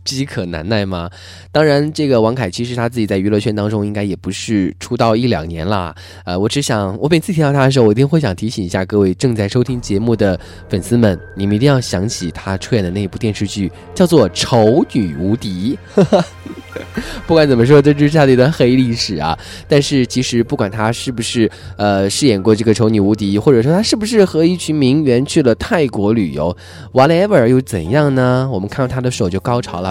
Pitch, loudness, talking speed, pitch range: 110 Hz, -14 LUFS, 340 characters per minute, 95-130 Hz